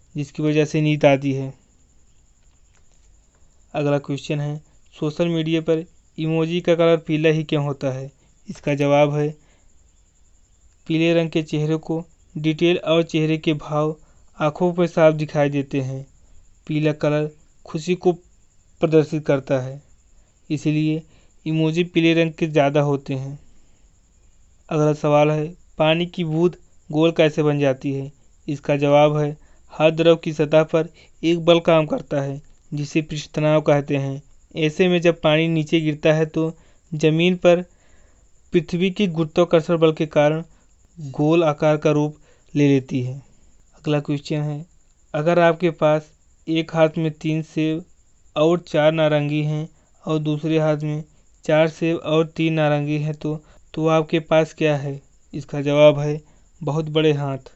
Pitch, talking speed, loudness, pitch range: 155 Hz, 150 wpm, -20 LUFS, 145-160 Hz